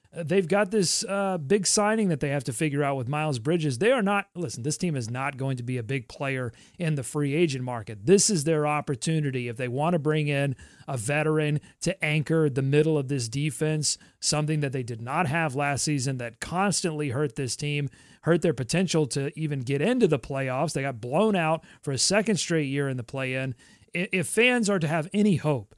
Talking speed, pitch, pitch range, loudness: 220 wpm, 150 Hz, 135-175 Hz, -26 LUFS